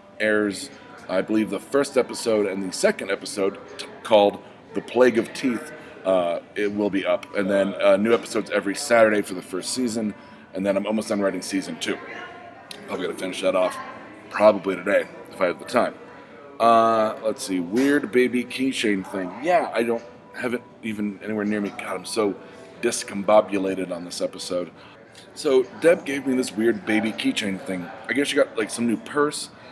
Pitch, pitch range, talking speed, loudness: 105 Hz, 100-120 Hz, 185 wpm, -23 LUFS